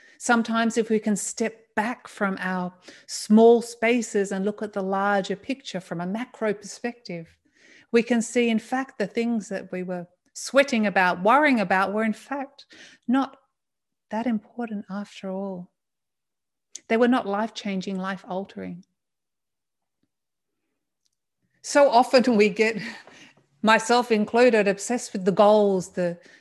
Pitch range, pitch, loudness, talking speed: 195-240 Hz, 220 Hz, -23 LUFS, 135 wpm